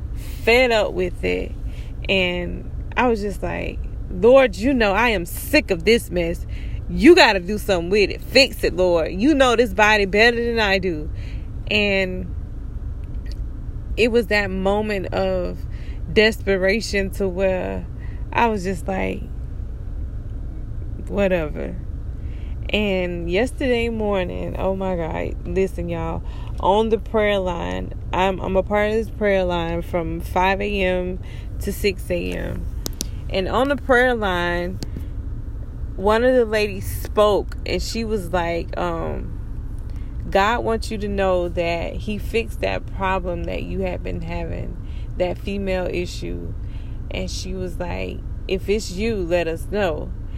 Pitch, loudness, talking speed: 175 Hz, -21 LUFS, 140 wpm